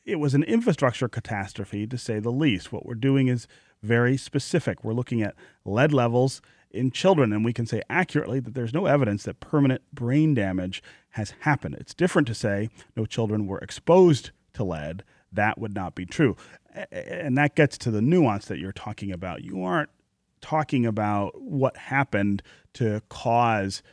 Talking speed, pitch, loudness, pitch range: 175 wpm, 120 Hz, -25 LUFS, 105-135 Hz